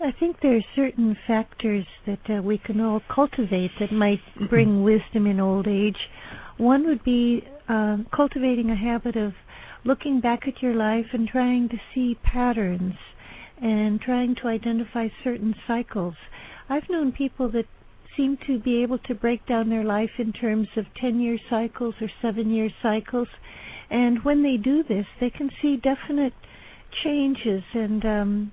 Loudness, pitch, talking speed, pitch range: -24 LUFS, 235 Hz, 165 wpm, 215-255 Hz